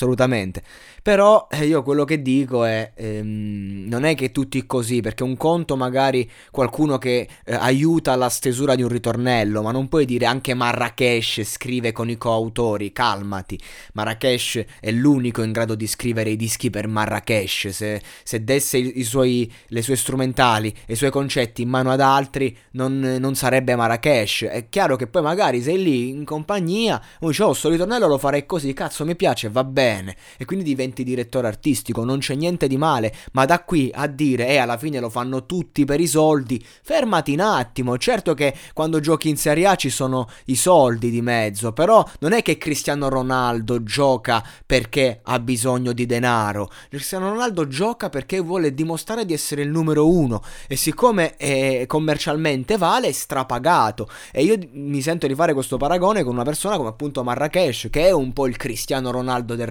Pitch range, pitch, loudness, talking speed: 120-150 Hz, 130 Hz, -20 LUFS, 185 wpm